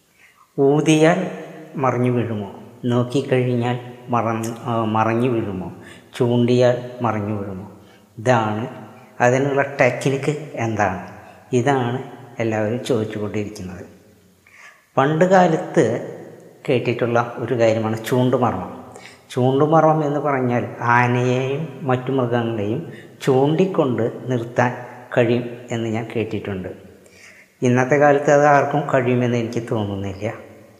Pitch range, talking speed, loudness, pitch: 110-135 Hz, 85 wpm, -20 LUFS, 120 Hz